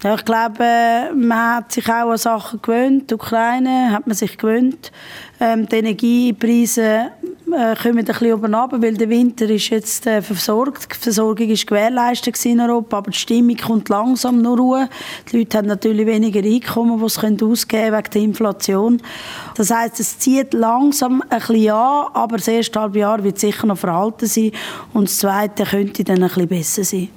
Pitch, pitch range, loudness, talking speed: 225 Hz, 215-235 Hz, -16 LUFS, 175 wpm